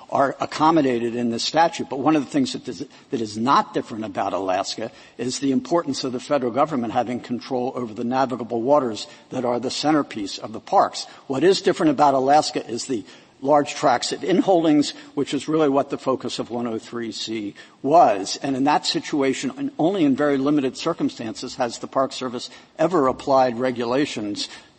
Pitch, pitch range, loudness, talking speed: 135 Hz, 120-150 Hz, -22 LUFS, 175 wpm